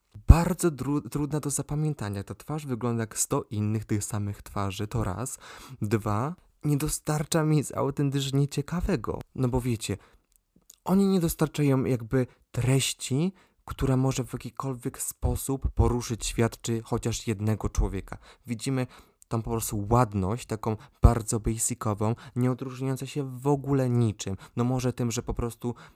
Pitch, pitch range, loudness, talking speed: 125 Hz, 110-140 Hz, -28 LUFS, 140 wpm